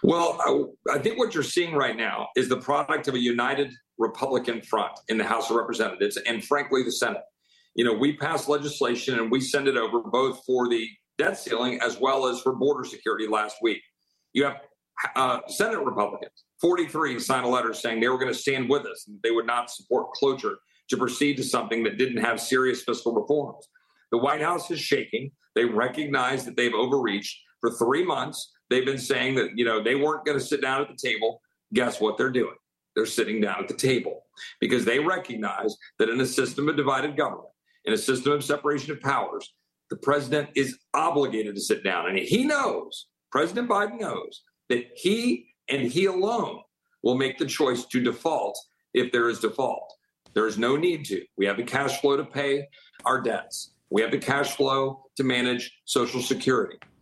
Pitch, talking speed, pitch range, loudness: 140 Hz, 195 wpm, 125-170 Hz, -26 LUFS